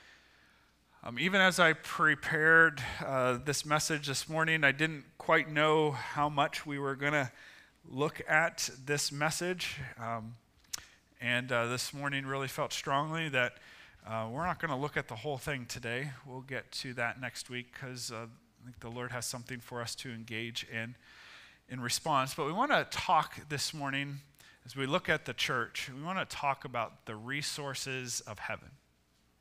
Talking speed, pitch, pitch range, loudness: 180 wpm, 135 Hz, 120-150 Hz, -32 LUFS